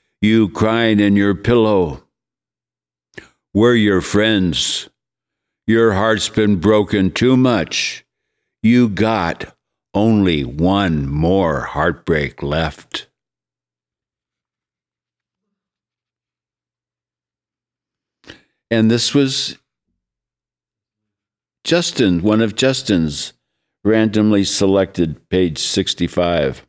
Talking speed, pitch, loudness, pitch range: 70 wpm, 100 Hz, -16 LUFS, 70-110 Hz